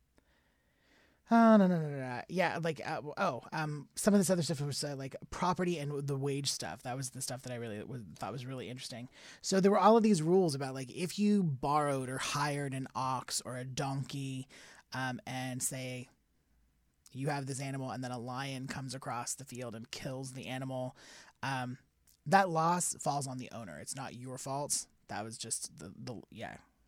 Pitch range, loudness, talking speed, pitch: 125-150 Hz, -34 LUFS, 205 wpm, 135 Hz